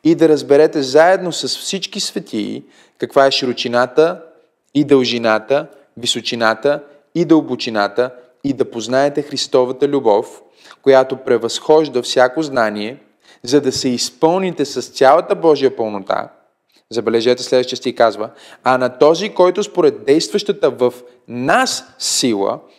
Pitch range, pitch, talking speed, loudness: 125-155 Hz, 135 Hz, 120 wpm, -15 LUFS